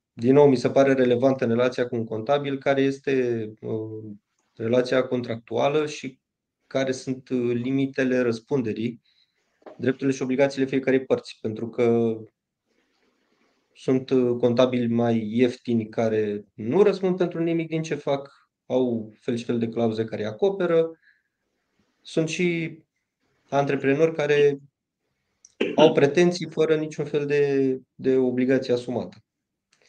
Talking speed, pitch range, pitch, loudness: 120 wpm, 120-140 Hz, 130 Hz, -24 LUFS